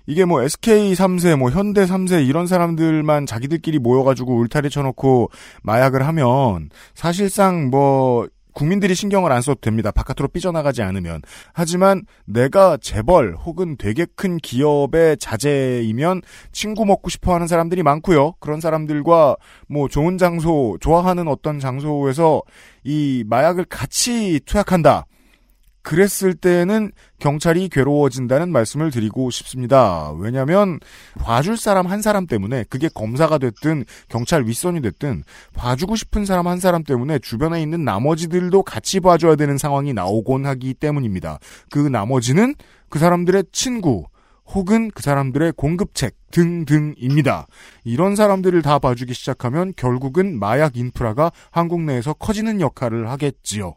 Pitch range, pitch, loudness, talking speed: 130-180 Hz, 150 Hz, -18 LUFS, 325 characters per minute